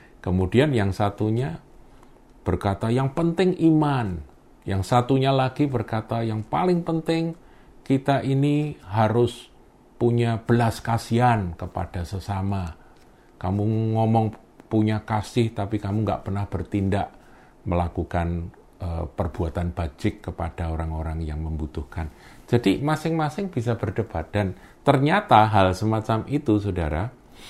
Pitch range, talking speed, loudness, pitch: 95-125 Hz, 105 wpm, -24 LUFS, 110 Hz